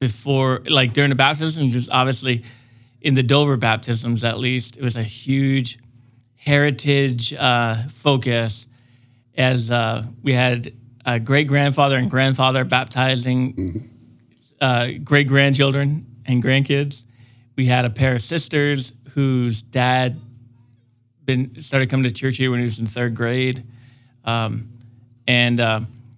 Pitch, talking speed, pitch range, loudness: 125 Hz, 135 wpm, 120-135 Hz, -19 LUFS